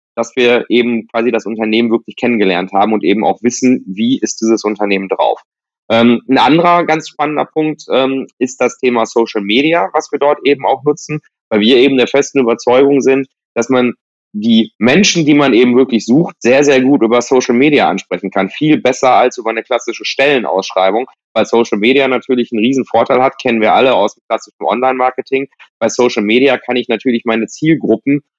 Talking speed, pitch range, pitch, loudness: 185 wpm, 115-140 Hz, 125 Hz, -12 LUFS